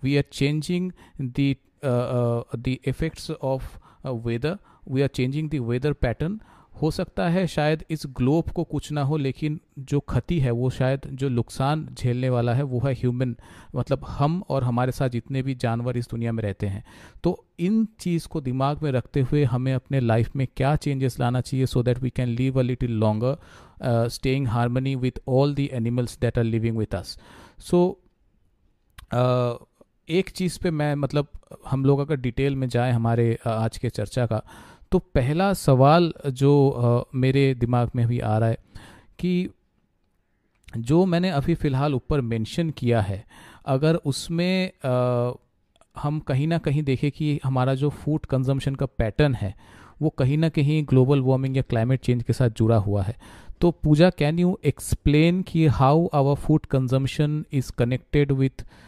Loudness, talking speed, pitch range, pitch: -24 LUFS, 170 wpm, 120-150 Hz, 130 Hz